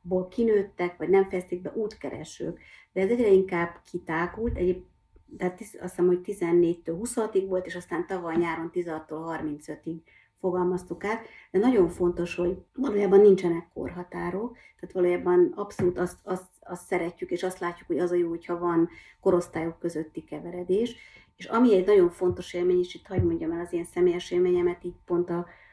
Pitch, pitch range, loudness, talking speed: 180 Hz, 175-185 Hz, -27 LUFS, 170 wpm